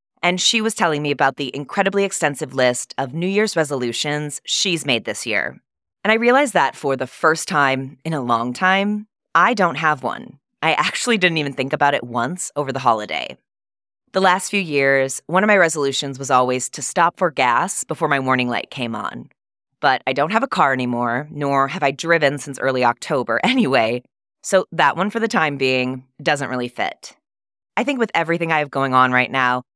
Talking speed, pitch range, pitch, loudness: 200 wpm, 130-180 Hz, 145 Hz, -19 LUFS